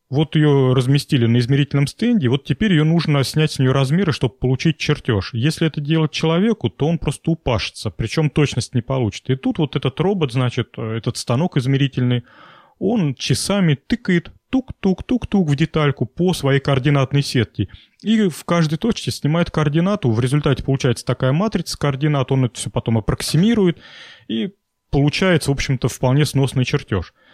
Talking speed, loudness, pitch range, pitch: 160 wpm, -19 LUFS, 130-160 Hz, 145 Hz